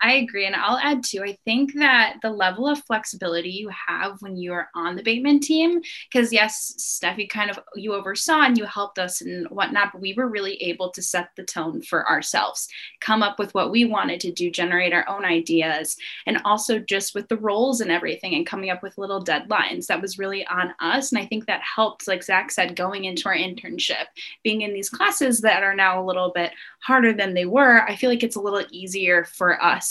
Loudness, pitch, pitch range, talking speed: -22 LUFS, 200 Hz, 185-235 Hz, 225 wpm